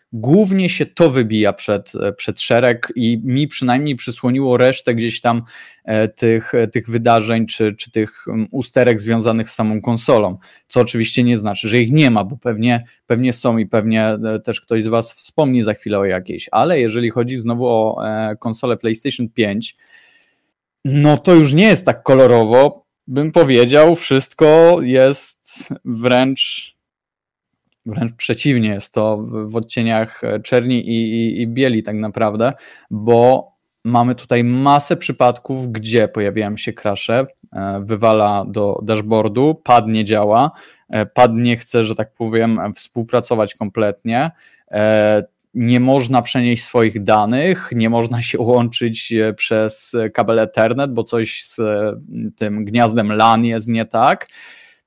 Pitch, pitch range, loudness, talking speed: 115 Hz, 110-125 Hz, -15 LUFS, 140 wpm